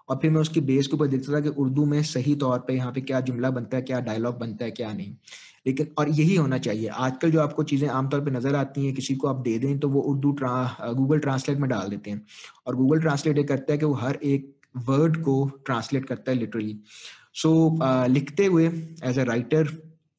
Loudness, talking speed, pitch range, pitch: -25 LUFS, 235 wpm, 125-150 Hz, 135 Hz